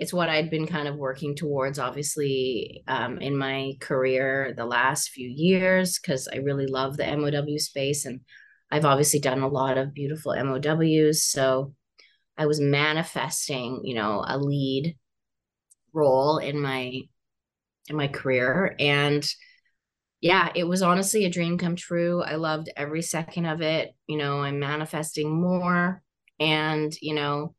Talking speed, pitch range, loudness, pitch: 150 wpm, 135-155 Hz, -25 LUFS, 145 Hz